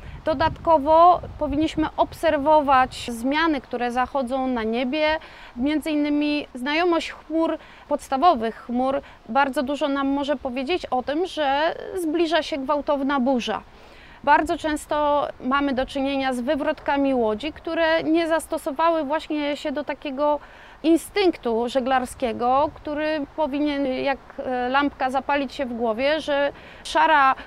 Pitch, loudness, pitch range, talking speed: 295 Hz, -23 LUFS, 270-315 Hz, 115 wpm